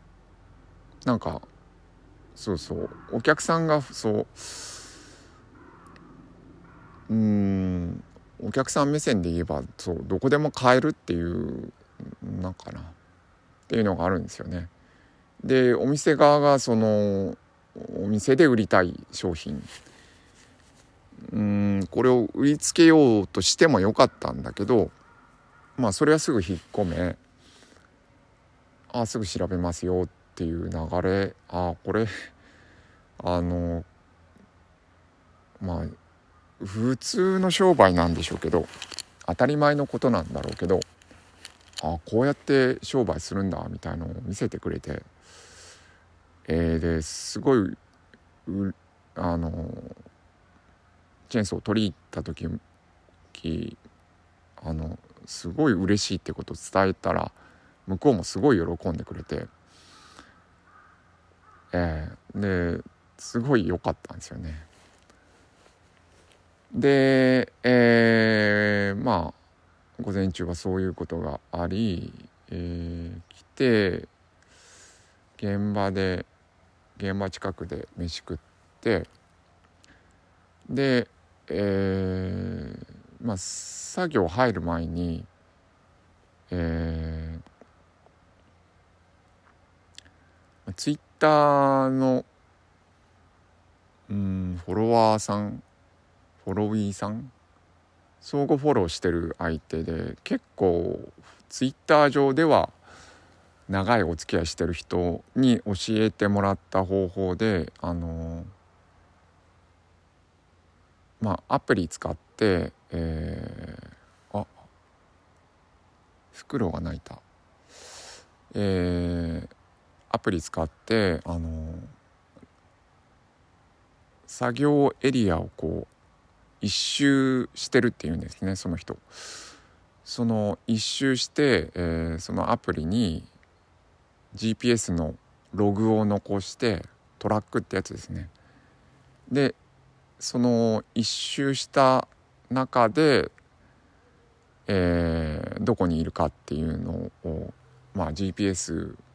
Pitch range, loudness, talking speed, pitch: 85-110 Hz, -25 LUFS, 190 characters per minute, 90 Hz